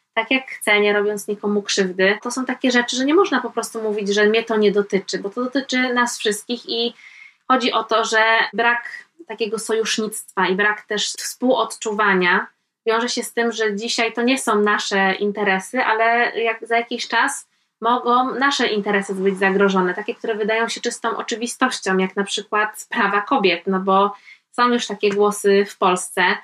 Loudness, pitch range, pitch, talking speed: -19 LUFS, 205-240 Hz, 220 Hz, 180 wpm